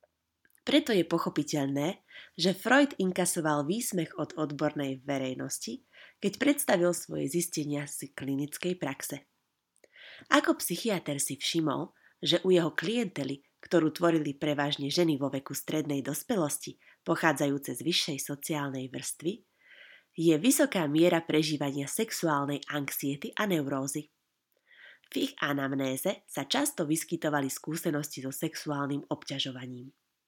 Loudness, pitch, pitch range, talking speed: -30 LUFS, 155 Hz, 140-180 Hz, 110 wpm